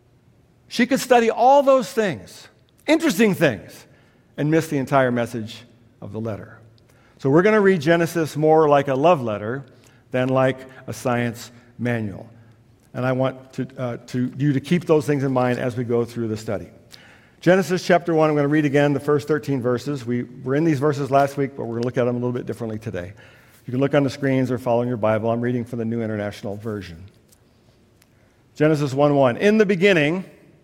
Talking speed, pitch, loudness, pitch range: 205 wpm, 130 Hz, -20 LUFS, 115-150 Hz